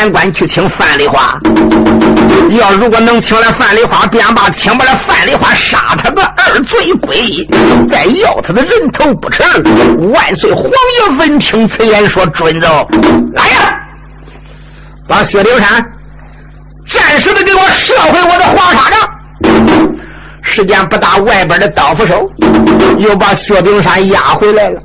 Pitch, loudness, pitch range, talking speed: 220 Hz, -6 LUFS, 195-315 Hz, 210 characters per minute